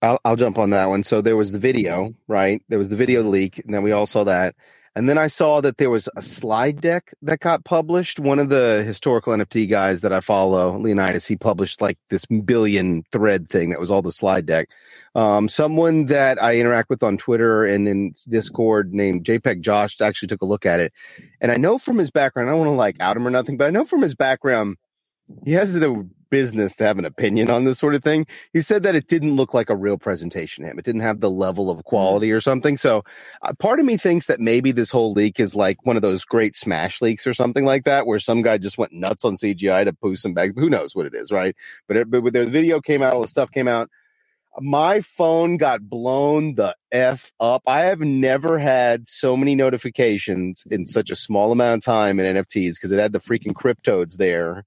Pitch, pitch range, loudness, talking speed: 115 Hz, 105-140 Hz, -19 LUFS, 240 wpm